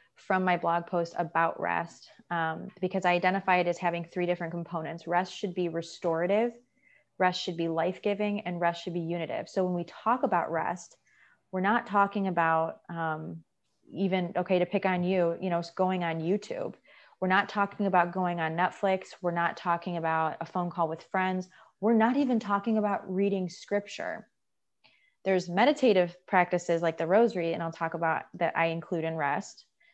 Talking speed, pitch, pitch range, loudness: 180 wpm, 180 Hz, 170-195 Hz, -29 LUFS